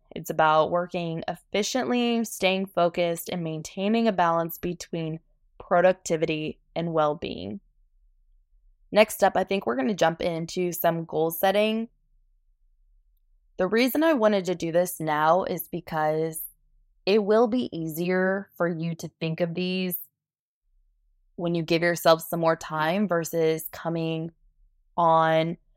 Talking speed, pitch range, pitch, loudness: 135 wpm, 160-185 Hz, 170 Hz, -25 LUFS